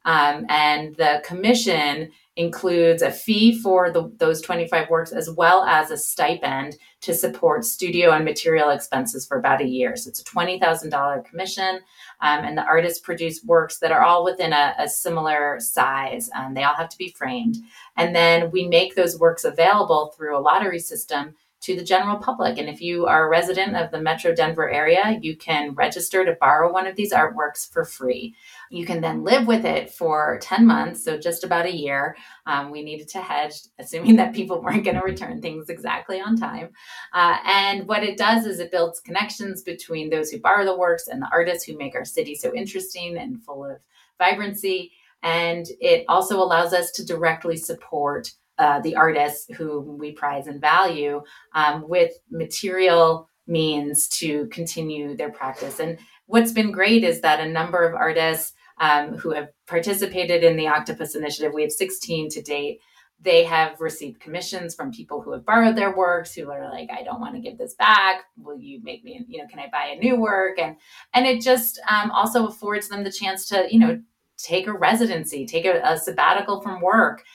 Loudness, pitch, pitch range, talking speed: -21 LUFS, 175 Hz, 160-220 Hz, 195 wpm